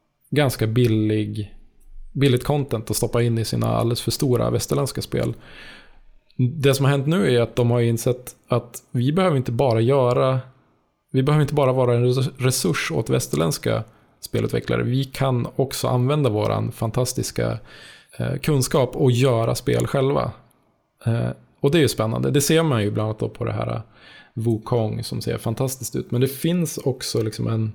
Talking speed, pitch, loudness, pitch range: 165 wpm, 125 Hz, -22 LUFS, 115-135 Hz